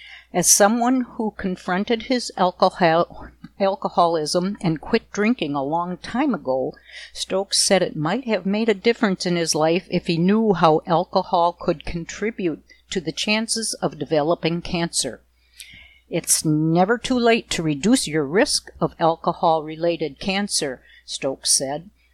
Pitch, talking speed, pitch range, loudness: 180 Hz, 140 wpm, 165-215 Hz, -21 LUFS